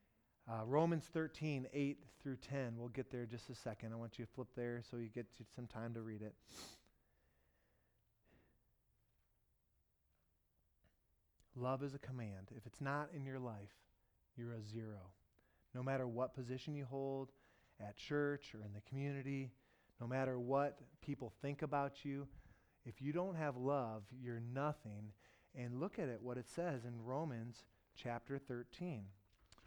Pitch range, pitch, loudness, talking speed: 110-140 Hz, 120 Hz, -46 LUFS, 155 wpm